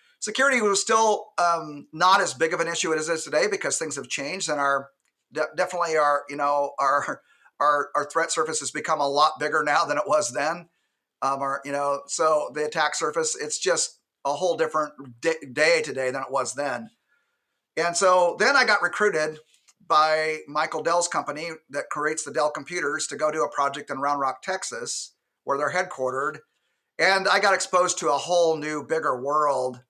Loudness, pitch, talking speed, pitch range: -24 LUFS, 155 Hz, 195 wpm, 145-190 Hz